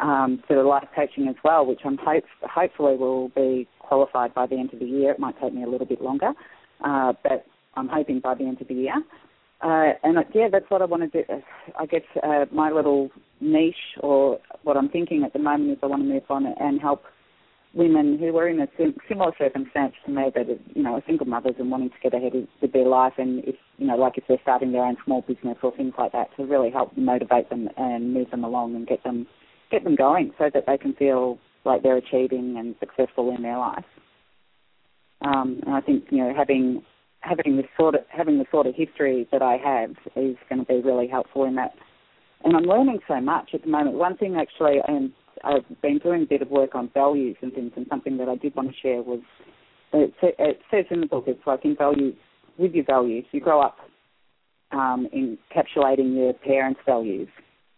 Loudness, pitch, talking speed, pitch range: -23 LUFS, 135 Hz, 225 wpm, 130-155 Hz